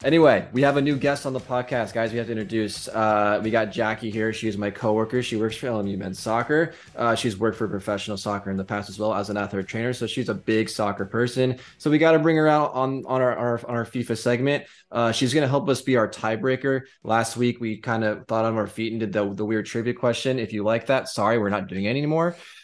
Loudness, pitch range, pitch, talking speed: -24 LUFS, 110-130 Hz, 115 Hz, 260 wpm